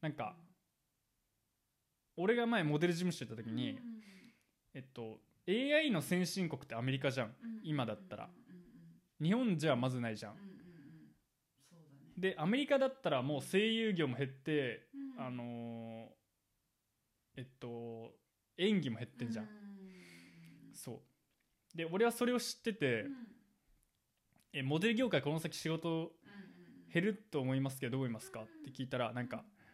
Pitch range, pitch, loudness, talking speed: 125-200 Hz, 155 Hz, -38 LUFS, 265 characters per minute